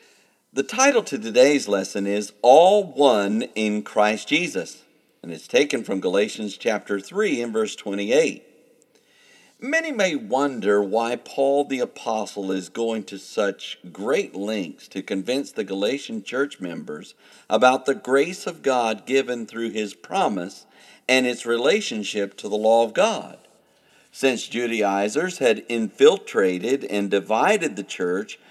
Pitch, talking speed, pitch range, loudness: 115 Hz, 135 wpm, 105-140 Hz, -22 LUFS